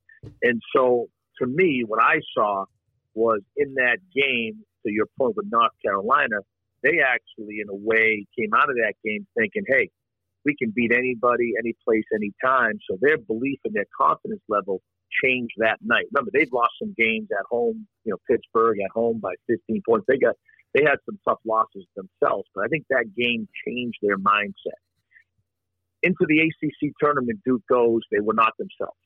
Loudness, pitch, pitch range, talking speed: -23 LUFS, 115 Hz, 110-130 Hz, 185 wpm